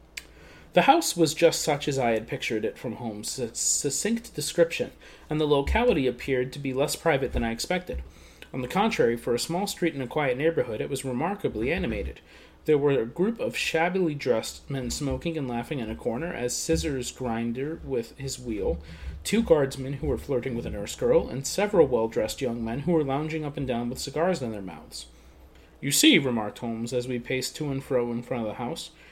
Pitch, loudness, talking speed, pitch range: 135 Hz, -27 LUFS, 210 wpm, 120-165 Hz